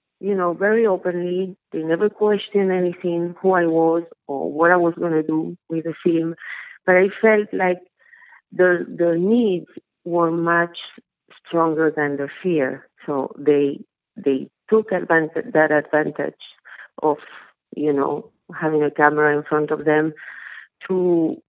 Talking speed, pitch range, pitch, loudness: 140 wpm, 155-185 Hz, 170 Hz, -20 LUFS